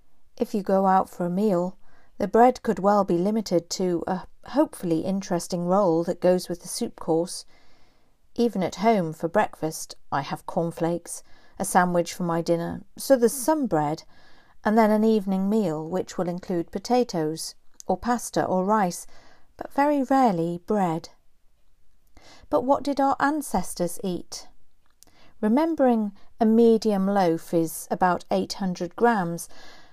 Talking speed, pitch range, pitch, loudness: 145 wpm, 170-230 Hz, 190 Hz, -24 LUFS